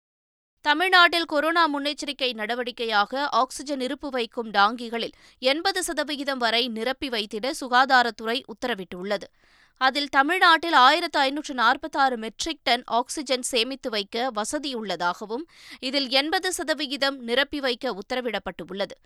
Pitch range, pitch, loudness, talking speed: 235-295 Hz, 260 Hz, -23 LUFS, 100 wpm